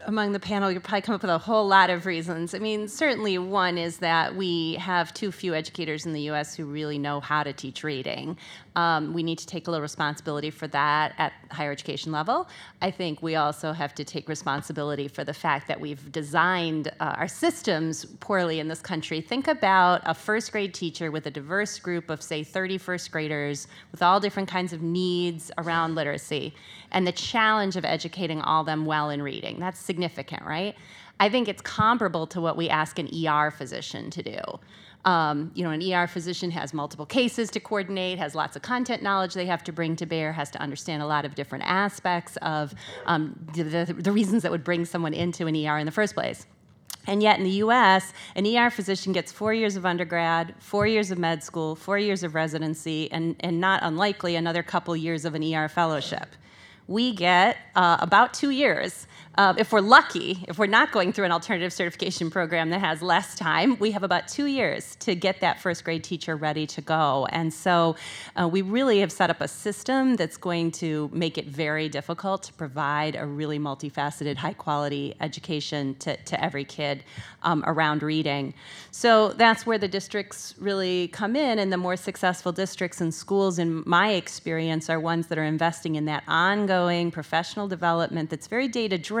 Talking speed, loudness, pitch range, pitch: 200 wpm, -26 LUFS, 155-195 Hz, 170 Hz